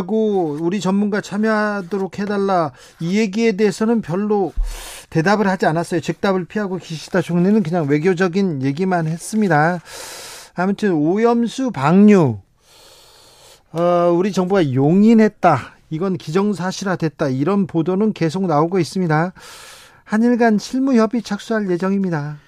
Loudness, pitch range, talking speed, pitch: -18 LUFS, 170-215 Hz, 300 characters per minute, 190 Hz